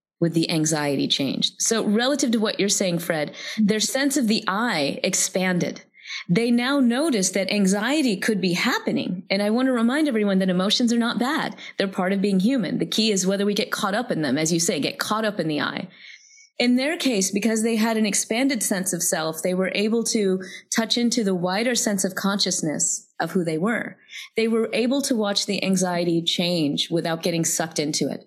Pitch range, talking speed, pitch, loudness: 185-235 Hz, 210 wpm, 205 Hz, -22 LUFS